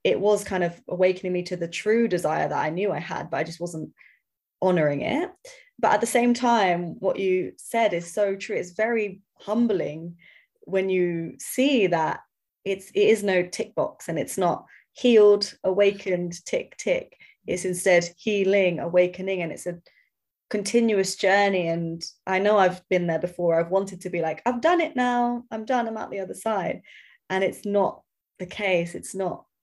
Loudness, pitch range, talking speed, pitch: -24 LUFS, 180-220 Hz, 185 wpm, 190 Hz